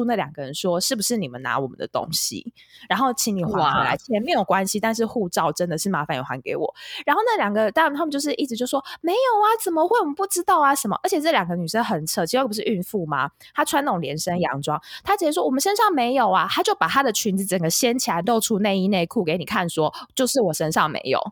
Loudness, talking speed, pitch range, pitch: -22 LUFS, 375 characters per minute, 180-290 Hz, 230 Hz